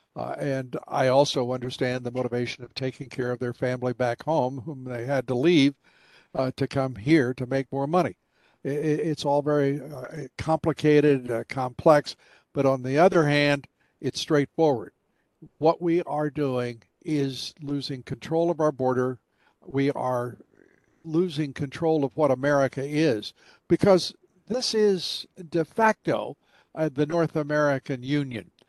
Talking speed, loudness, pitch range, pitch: 150 wpm, -25 LUFS, 130-155 Hz, 140 Hz